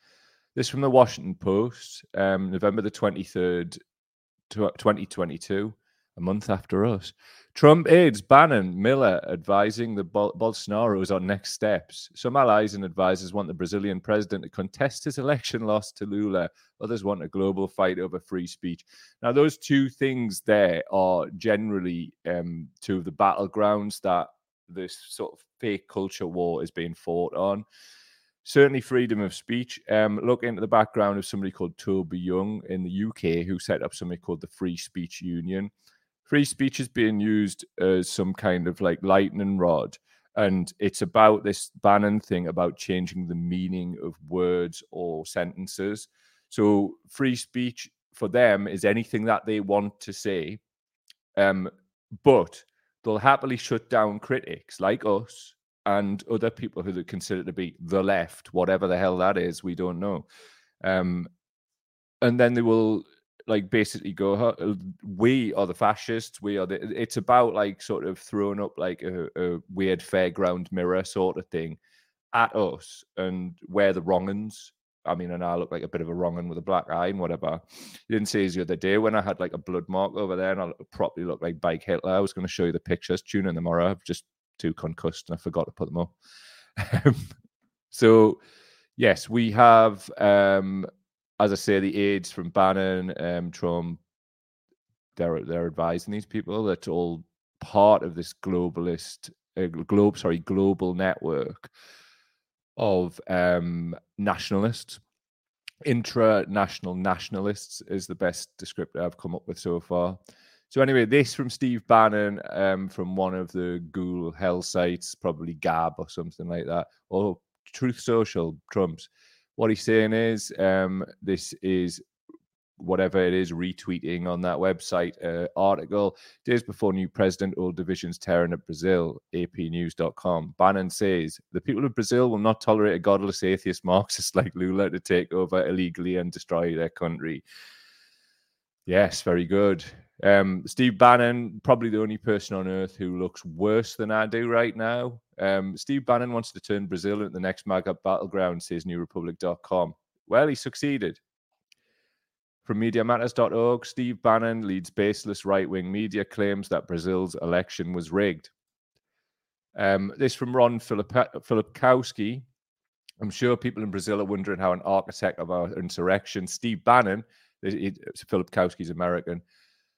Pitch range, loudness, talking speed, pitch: 90-110 Hz, -25 LUFS, 160 wpm, 95 Hz